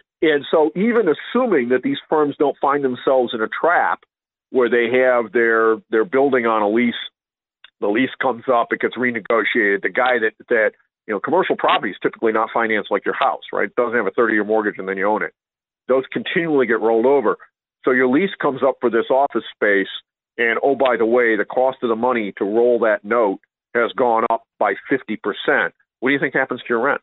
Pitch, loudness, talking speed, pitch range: 130 Hz, -18 LUFS, 220 wpm, 115-150 Hz